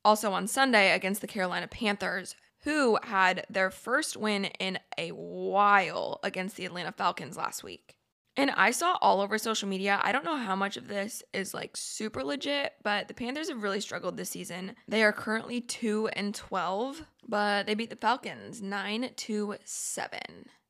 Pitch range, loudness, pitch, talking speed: 195-235 Hz, -30 LUFS, 210 Hz, 175 wpm